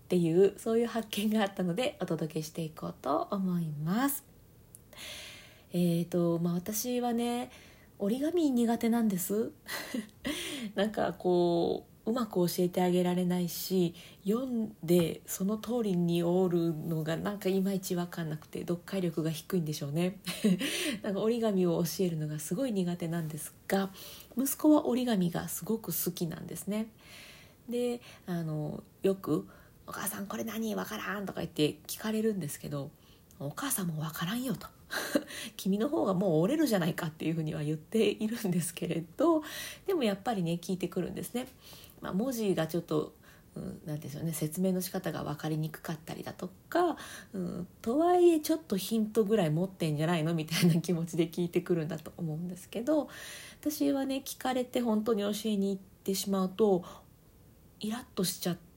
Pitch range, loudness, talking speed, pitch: 170-225 Hz, -32 LUFS, 345 characters per minute, 185 Hz